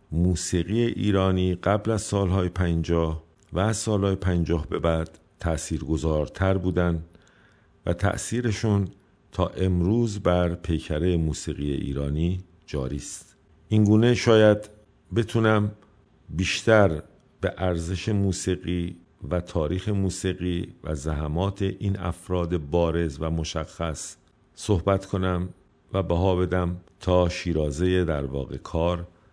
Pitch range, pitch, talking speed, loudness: 85-100 Hz, 90 Hz, 105 wpm, -25 LUFS